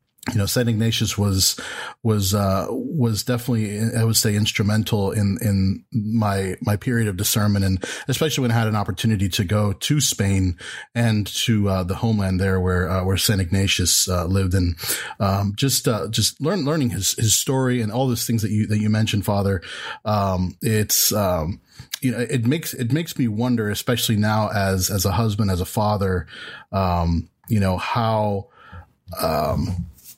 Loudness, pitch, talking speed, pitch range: -21 LUFS, 105 Hz, 175 wpm, 95-115 Hz